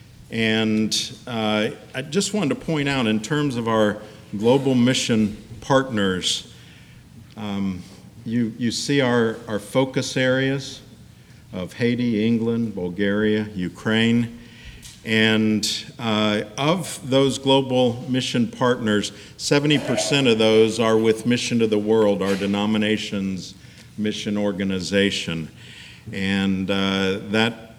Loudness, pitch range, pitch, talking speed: -21 LUFS, 105-125 Hz, 110 Hz, 110 wpm